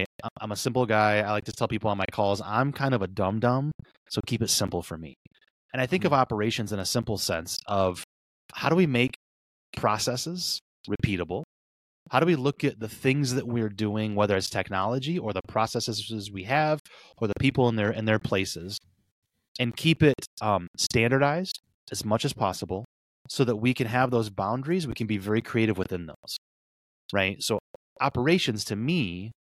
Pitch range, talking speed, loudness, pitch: 100-130 Hz, 190 wpm, -27 LUFS, 110 Hz